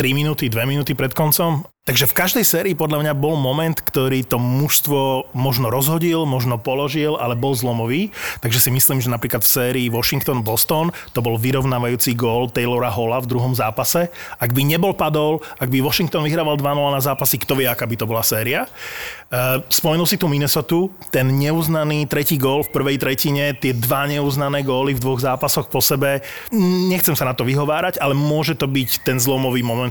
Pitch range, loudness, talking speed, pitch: 130-155 Hz, -18 LUFS, 185 wpm, 140 Hz